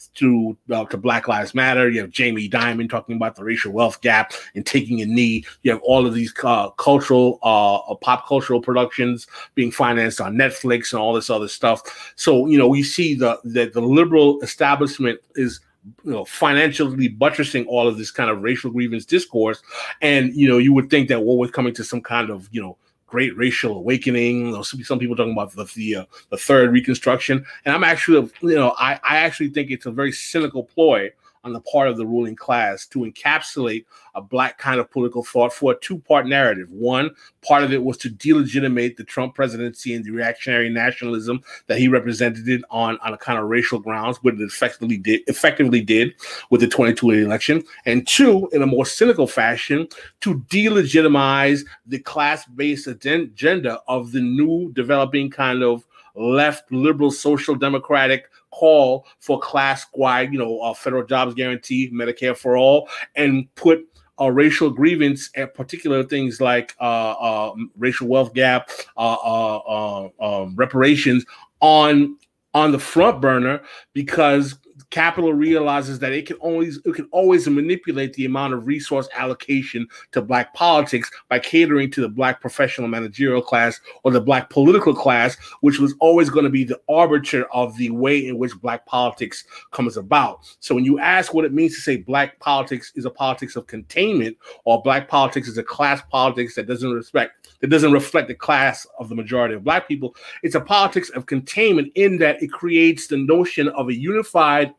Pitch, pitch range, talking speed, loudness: 130 Hz, 120-145 Hz, 185 wpm, -18 LUFS